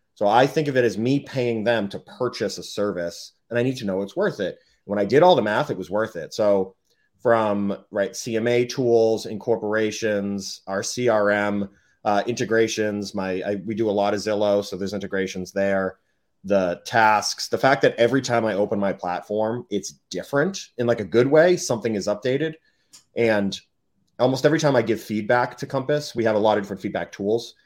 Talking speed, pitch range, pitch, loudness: 195 wpm, 100-120 Hz, 110 Hz, -22 LUFS